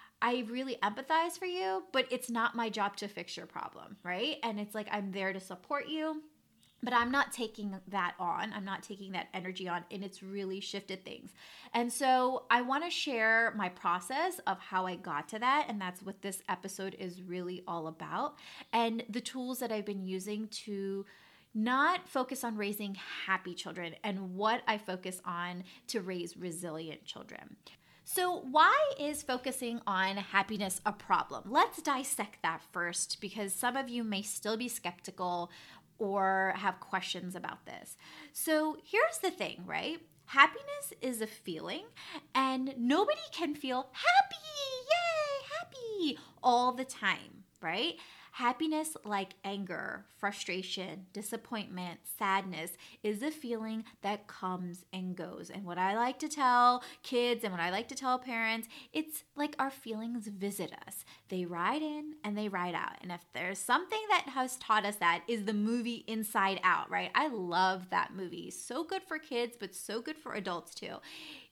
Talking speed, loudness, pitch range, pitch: 165 wpm, -34 LUFS, 190-260 Hz, 220 Hz